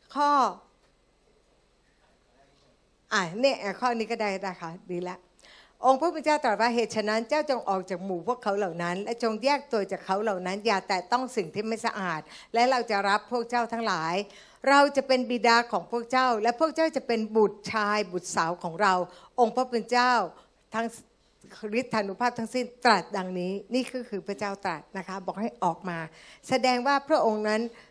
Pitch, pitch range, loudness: 220 Hz, 195-245 Hz, -27 LUFS